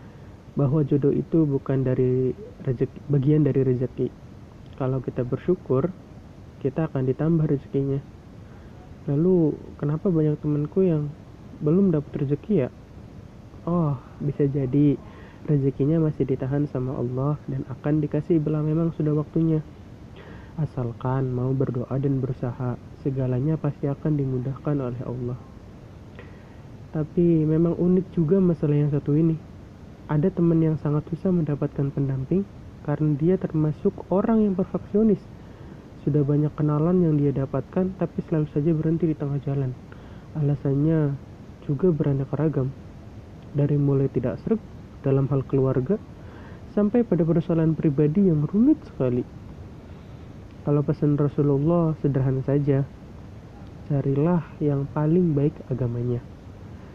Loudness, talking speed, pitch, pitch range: -24 LUFS, 120 wpm, 145 Hz, 130-155 Hz